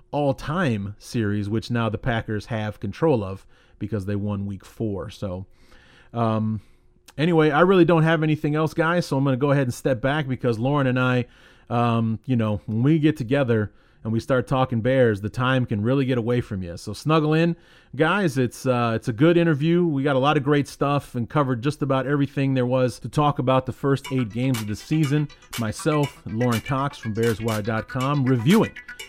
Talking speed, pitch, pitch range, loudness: 200 wpm, 130 Hz, 115-145 Hz, -23 LUFS